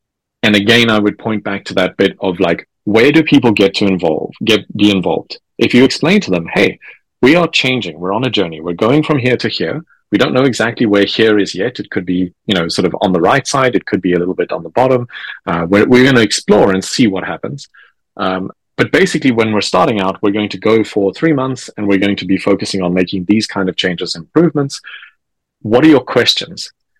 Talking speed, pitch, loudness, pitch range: 240 wpm, 105 Hz, -13 LUFS, 95-125 Hz